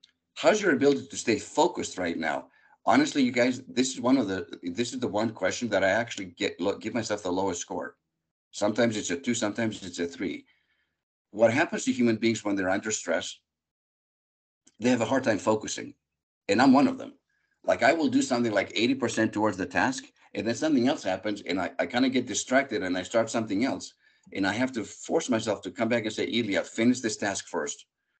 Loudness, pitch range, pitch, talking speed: -27 LUFS, 105-135 Hz, 115 Hz, 220 wpm